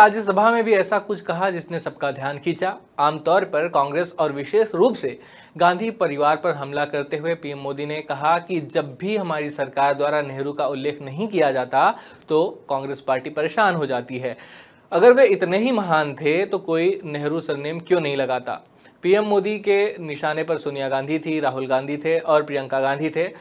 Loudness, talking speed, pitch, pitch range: -21 LUFS, 190 wpm, 155 Hz, 140-185 Hz